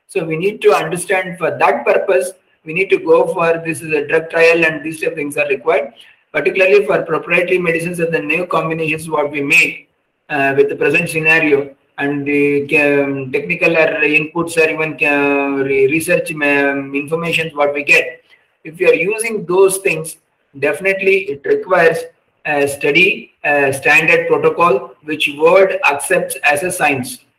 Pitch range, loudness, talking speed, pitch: 145-190 Hz, -14 LUFS, 160 wpm, 160 Hz